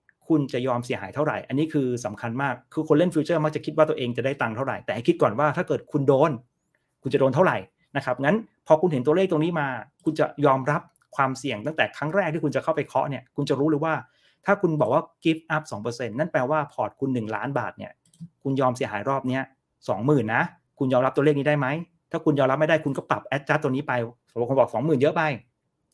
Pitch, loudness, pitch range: 145 Hz, -24 LUFS, 130-155 Hz